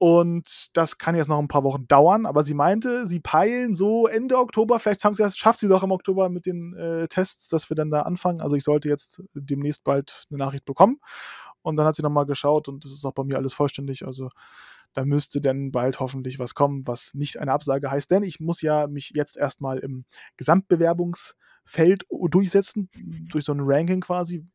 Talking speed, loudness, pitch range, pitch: 210 wpm, -23 LUFS, 140-185 Hz, 155 Hz